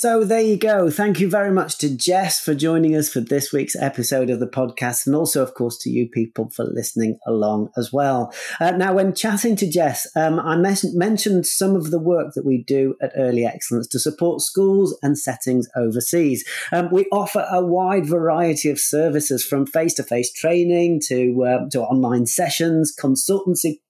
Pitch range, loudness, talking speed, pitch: 130-180 Hz, -19 LUFS, 190 wpm, 155 Hz